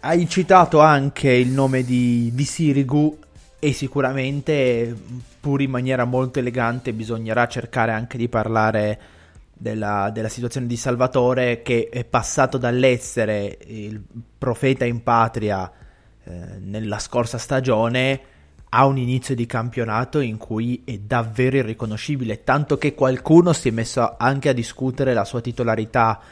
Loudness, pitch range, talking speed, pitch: -20 LUFS, 115-135 Hz, 135 wpm, 120 Hz